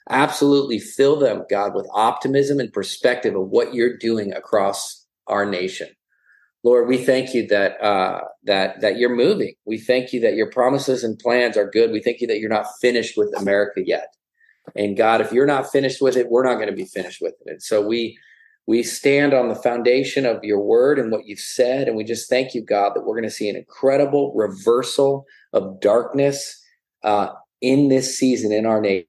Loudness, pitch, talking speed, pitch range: -20 LUFS, 125 Hz, 205 wpm, 115-140 Hz